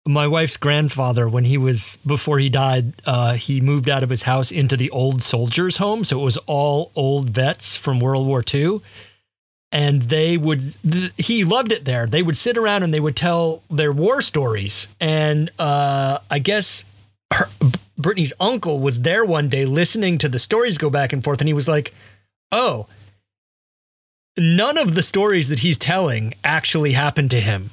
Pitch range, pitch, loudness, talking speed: 130-165 Hz, 145 Hz, -19 LUFS, 185 wpm